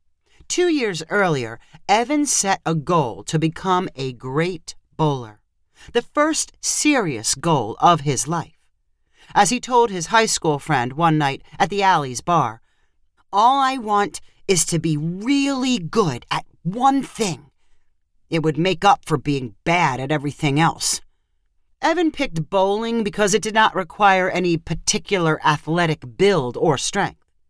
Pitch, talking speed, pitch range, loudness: 170 Hz, 145 wpm, 150-210 Hz, -20 LUFS